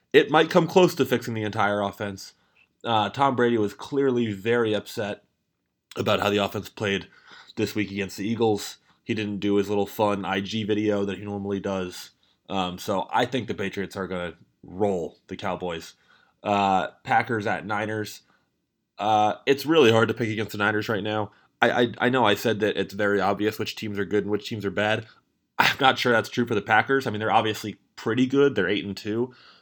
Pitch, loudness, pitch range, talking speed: 105 Hz, -24 LUFS, 100-115 Hz, 205 wpm